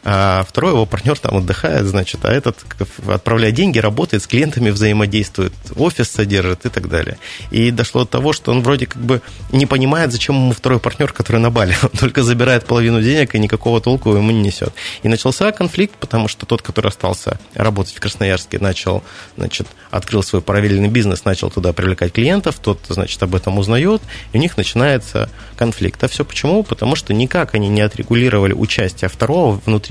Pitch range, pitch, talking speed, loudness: 100-125 Hz, 110 Hz, 185 wpm, -16 LUFS